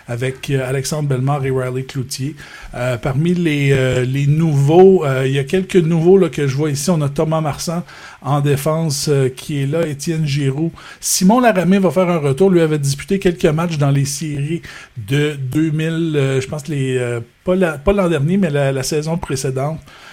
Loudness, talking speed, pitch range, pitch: -16 LUFS, 200 wpm, 135-170 Hz, 150 Hz